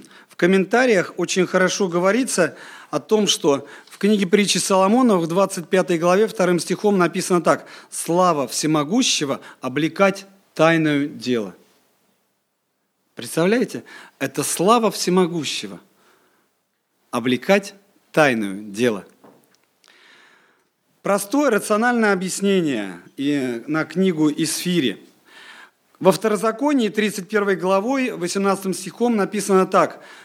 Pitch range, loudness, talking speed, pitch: 160-200 Hz, -19 LUFS, 90 wpm, 185 Hz